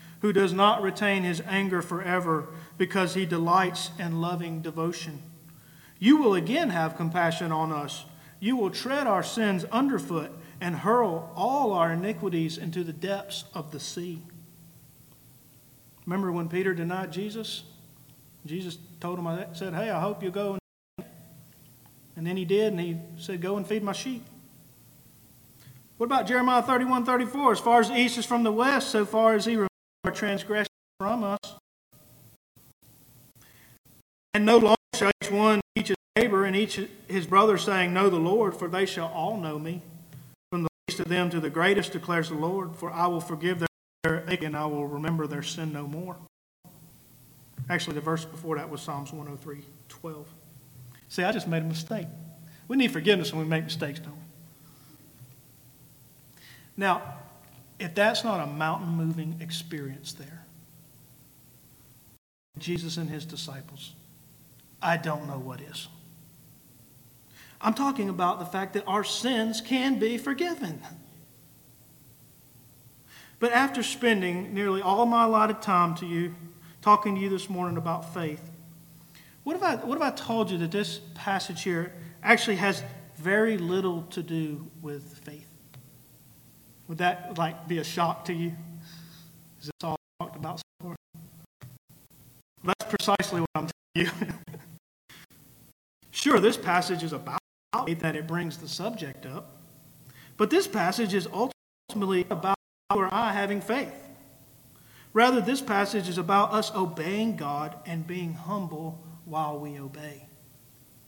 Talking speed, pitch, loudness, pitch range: 150 wpm, 170 Hz, -27 LUFS, 150-200 Hz